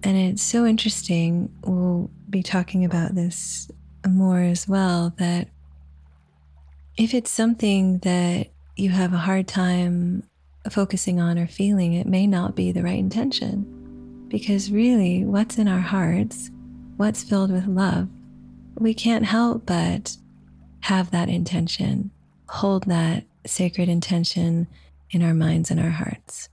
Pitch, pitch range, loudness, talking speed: 180 Hz, 170-195 Hz, -22 LUFS, 135 wpm